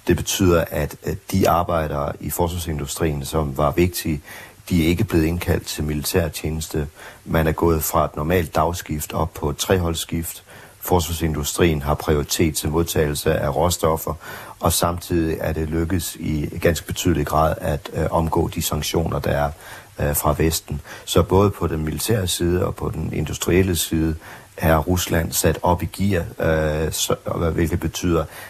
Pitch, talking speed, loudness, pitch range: 85 Hz, 150 wpm, -21 LUFS, 80-90 Hz